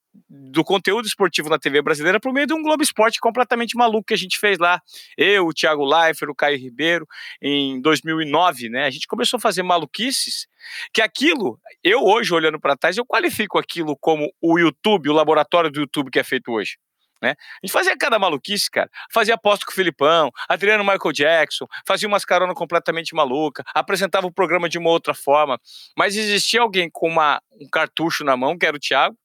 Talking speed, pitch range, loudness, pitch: 195 wpm, 155-225 Hz, -19 LUFS, 180 Hz